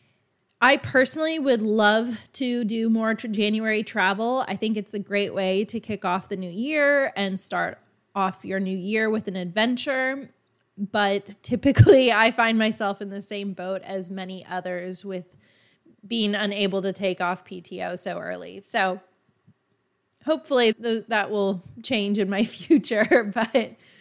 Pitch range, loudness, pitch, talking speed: 190-230 Hz, -23 LUFS, 205 Hz, 155 wpm